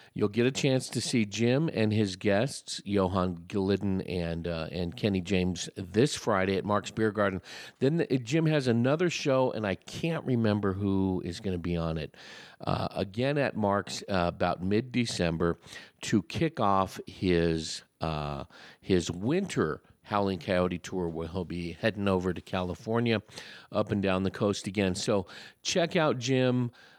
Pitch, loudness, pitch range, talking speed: 100 Hz, -29 LUFS, 90-115 Hz, 170 wpm